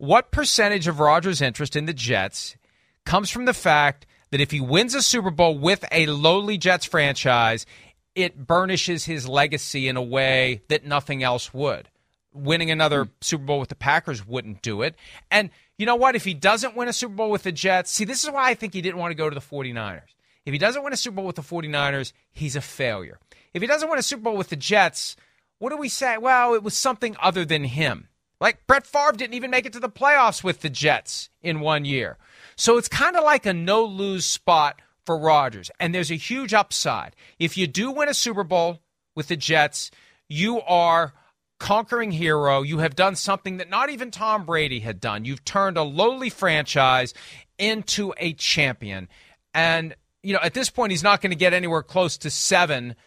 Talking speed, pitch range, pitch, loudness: 210 wpm, 145-215 Hz, 175 Hz, -22 LUFS